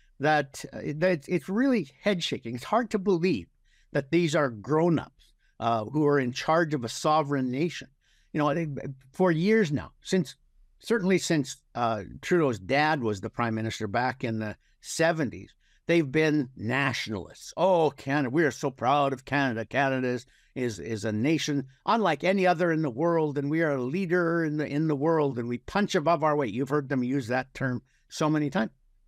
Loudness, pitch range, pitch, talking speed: -27 LUFS, 125-165 Hz, 145 Hz, 190 wpm